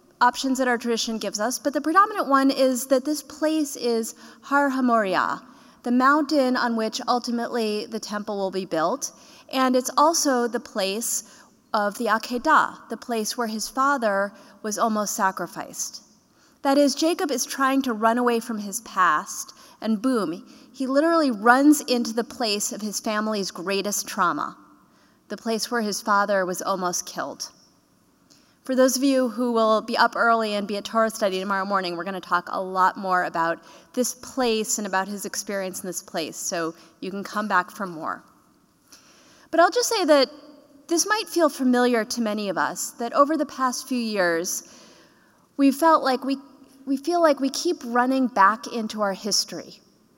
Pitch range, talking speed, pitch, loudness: 205-270 Hz, 175 wpm, 235 Hz, -23 LUFS